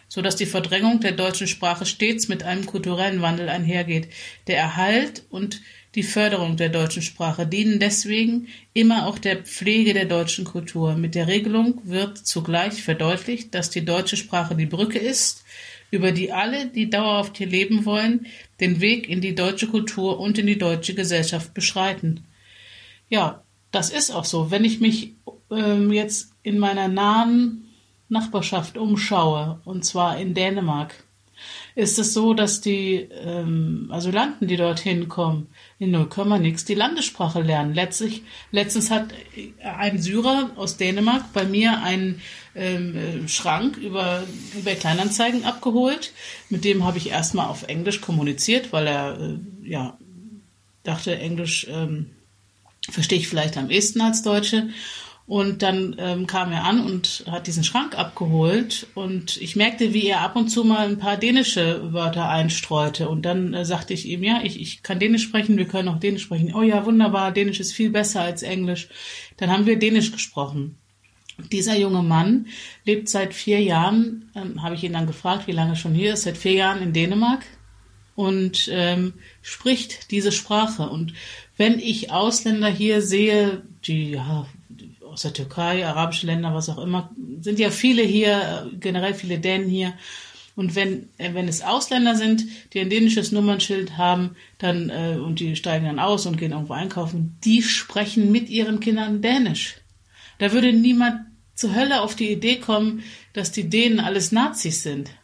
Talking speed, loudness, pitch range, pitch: 165 wpm, -22 LUFS, 170-215 Hz, 195 Hz